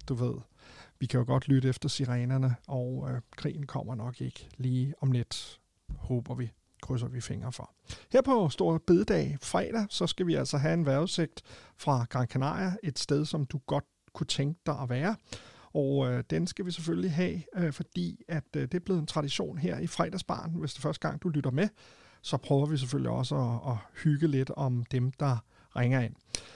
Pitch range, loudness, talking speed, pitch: 125-170 Hz, -31 LUFS, 200 wpm, 140 Hz